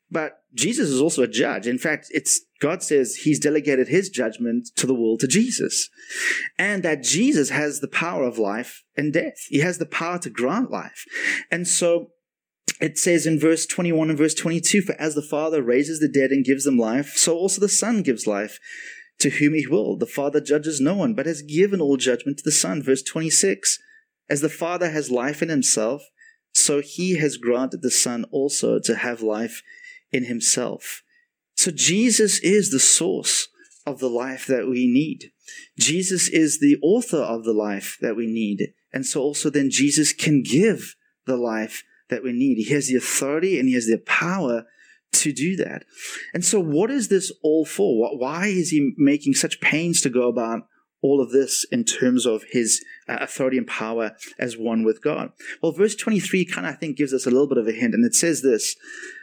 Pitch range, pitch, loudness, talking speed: 130-205 Hz, 155 Hz, -21 LUFS, 200 wpm